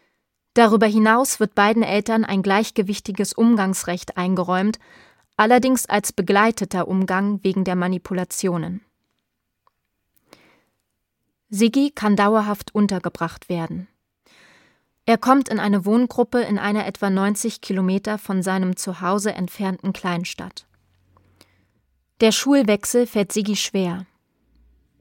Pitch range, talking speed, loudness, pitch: 185-220 Hz, 100 wpm, -20 LUFS, 200 Hz